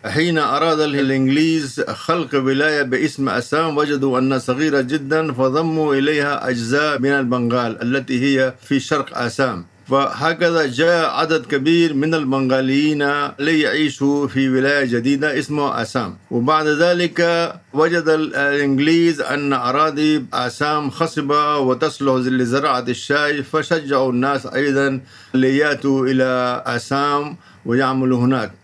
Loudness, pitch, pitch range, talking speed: -18 LUFS, 140 Hz, 130-155 Hz, 110 wpm